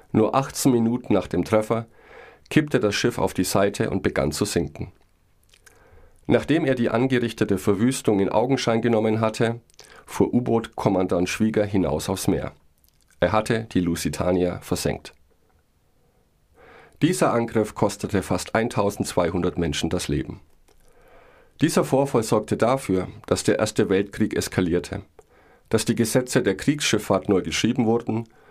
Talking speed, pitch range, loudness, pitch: 130 wpm, 95-120 Hz, -23 LUFS, 110 Hz